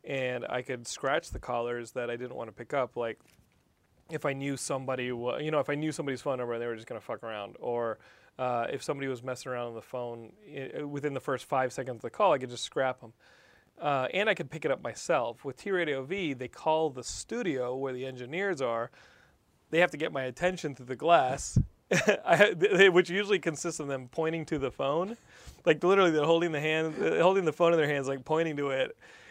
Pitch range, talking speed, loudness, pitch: 125-160 Hz, 235 wpm, -30 LUFS, 135 Hz